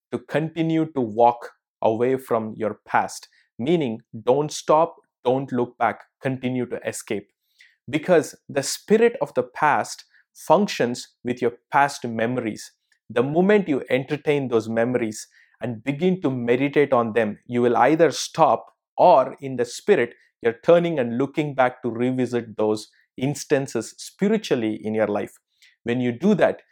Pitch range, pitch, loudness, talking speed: 115-145 Hz, 125 Hz, -22 LUFS, 145 wpm